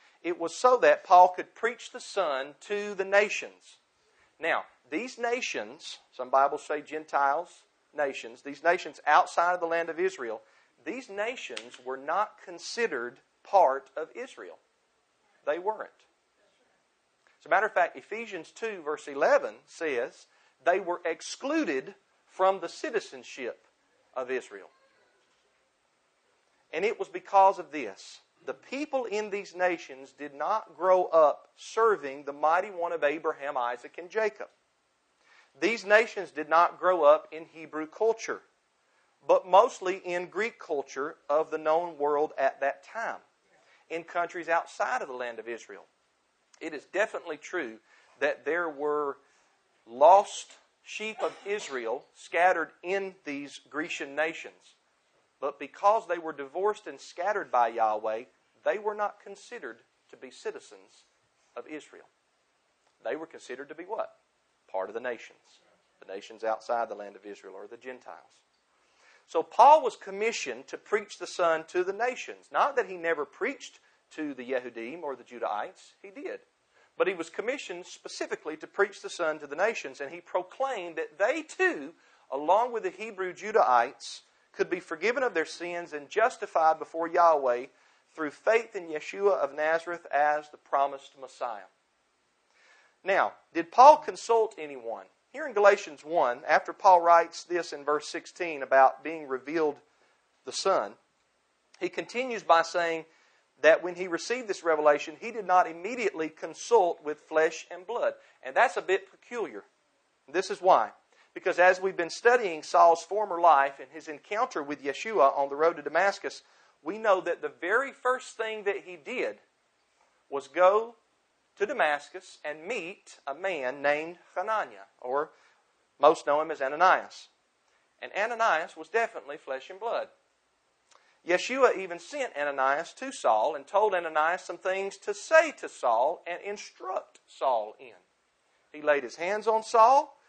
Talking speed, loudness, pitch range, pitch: 150 wpm, -28 LUFS, 150-225 Hz, 175 Hz